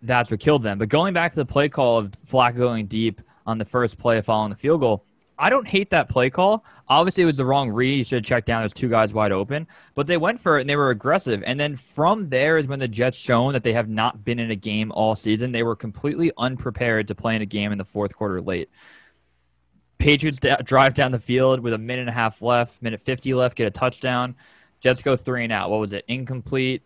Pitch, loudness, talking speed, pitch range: 125 Hz, -21 LUFS, 255 wpm, 110-135 Hz